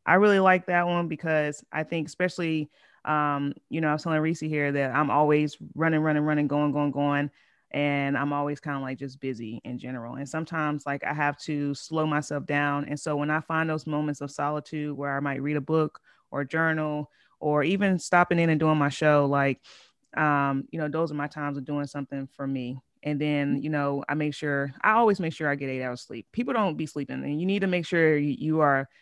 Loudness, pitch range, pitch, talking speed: -27 LUFS, 140-155 Hz, 150 Hz, 230 wpm